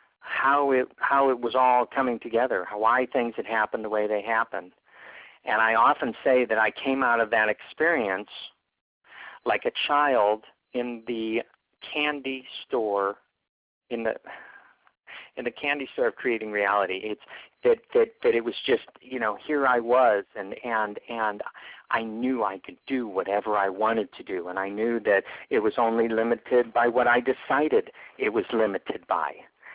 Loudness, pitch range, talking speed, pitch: -25 LUFS, 110-135 Hz, 175 wpm, 120 Hz